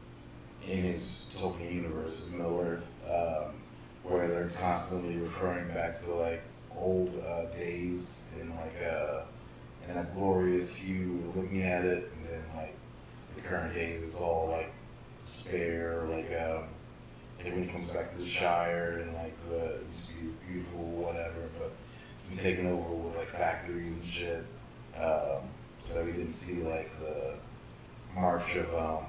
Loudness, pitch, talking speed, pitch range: -35 LUFS, 85 Hz, 150 wpm, 80-90 Hz